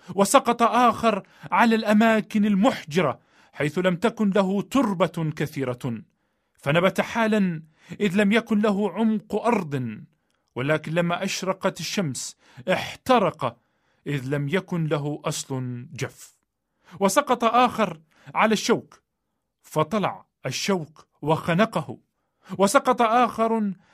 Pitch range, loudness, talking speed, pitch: 155-220 Hz, -23 LUFS, 100 wpm, 190 Hz